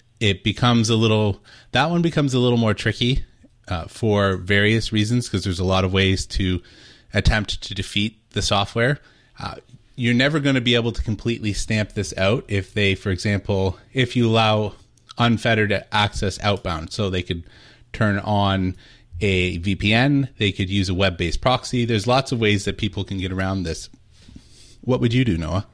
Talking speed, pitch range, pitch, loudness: 180 wpm, 95-115 Hz, 105 Hz, -21 LUFS